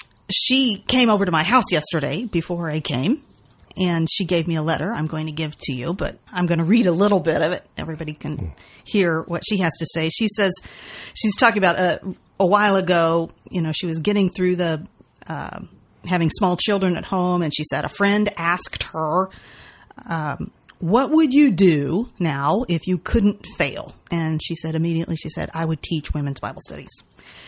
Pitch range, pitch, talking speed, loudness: 160-200 Hz, 175 Hz, 200 wpm, -20 LUFS